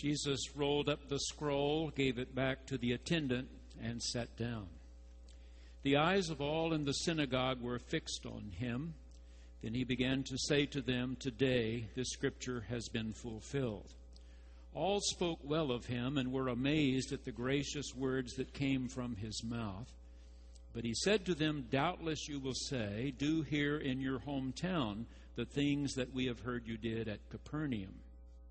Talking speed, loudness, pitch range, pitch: 165 wpm, -38 LUFS, 115-145 Hz, 130 Hz